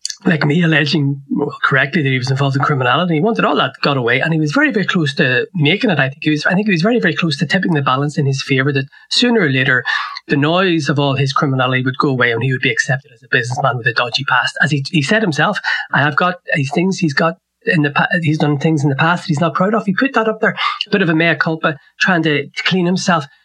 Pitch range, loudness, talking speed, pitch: 140-180 Hz, -15 LUFS, 285 wpm, 160 Hz